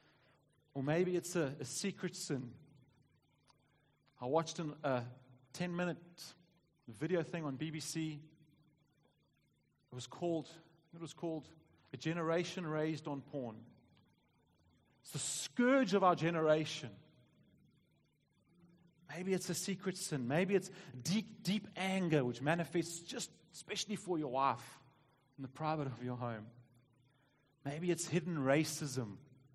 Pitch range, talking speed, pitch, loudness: 135-170 Hz, 125 wpm, 155 Hz, -38 LUFS